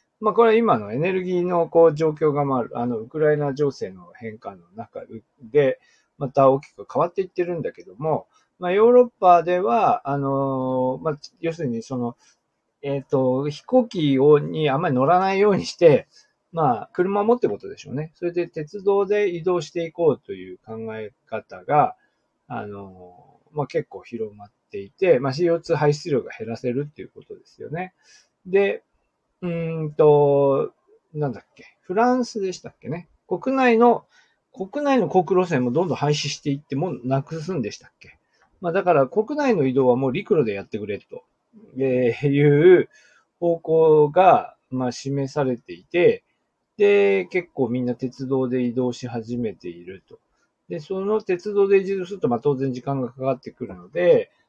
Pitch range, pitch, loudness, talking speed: 135-195 Hz, 160 Hz, -21 LUFS, 320 characters per minute